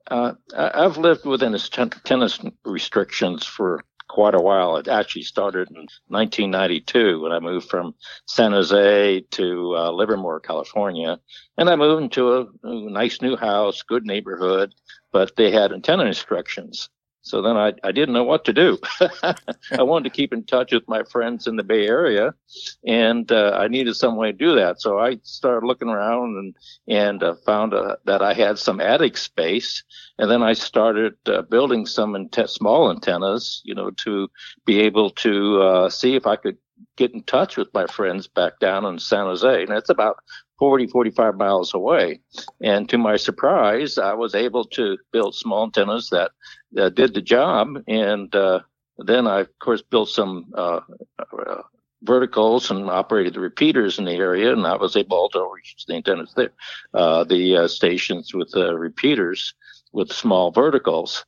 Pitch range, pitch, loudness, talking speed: 105-160 Hz, 120 Hz, -20 LUFS, 180 wpm